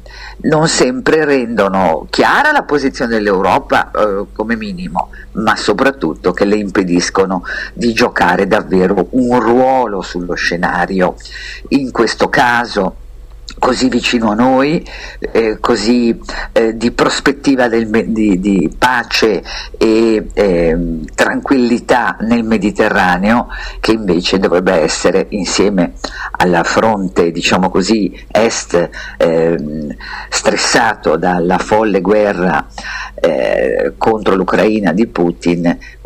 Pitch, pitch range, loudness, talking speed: 110 Hz, 90-125 Hz, -13 LUFS, 105 wpm